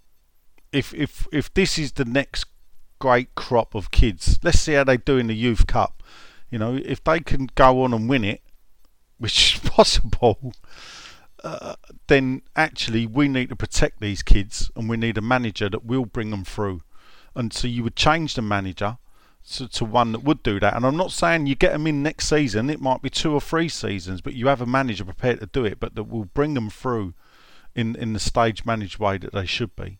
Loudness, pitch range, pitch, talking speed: -22 LUFS, 105-135 Hz, 120 Hz, 215 wpm